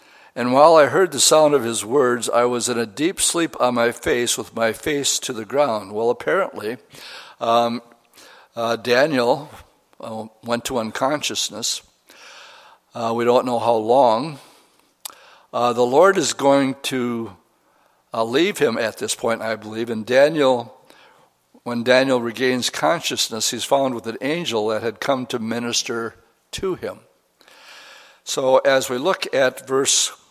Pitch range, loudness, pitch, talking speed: 115-135 Hz, -19 LUFS, 120 Hz, 150 wpm